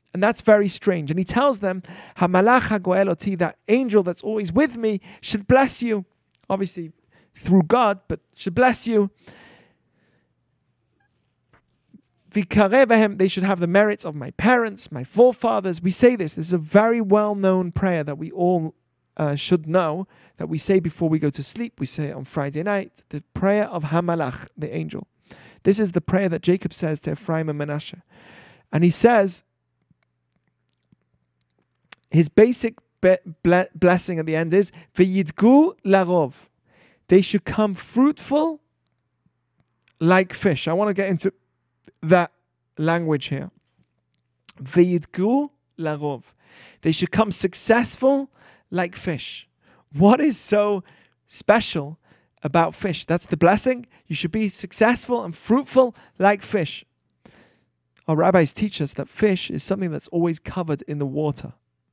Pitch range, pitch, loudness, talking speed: 160-210 Hz, 180 Hz, -21 LUFS, 140 wpm